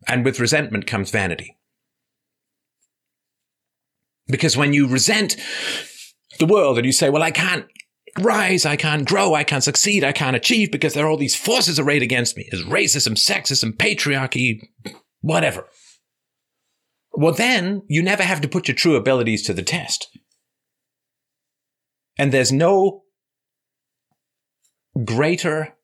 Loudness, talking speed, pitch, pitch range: -18 LUFS, 135 wpm, 145 Hz, 130-165 Hz